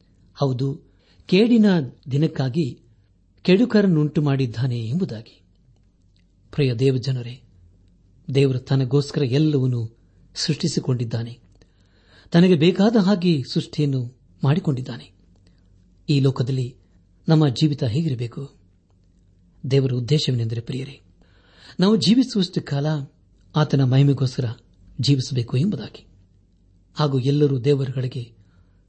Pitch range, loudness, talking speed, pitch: 95-145 Hz, -21 LUFS, 75 wpm, 130 Hz